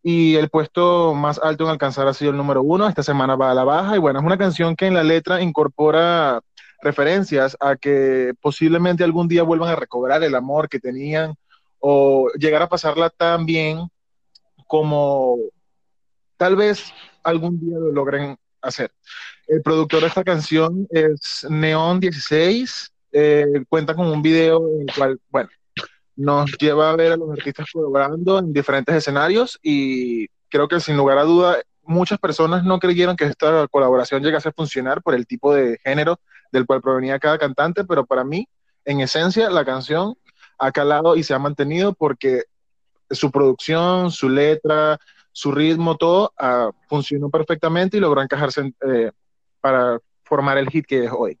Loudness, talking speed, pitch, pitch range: -18 LUFS, 170 wpm, 155 Hz, 140-165 Hz